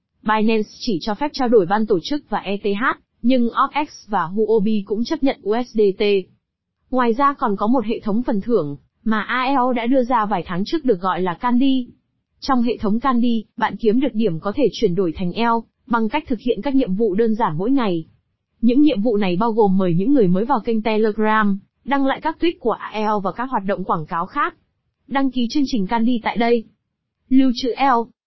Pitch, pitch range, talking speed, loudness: 225 Hz, 205-255 Hz, 215 wpm, -19 LUFS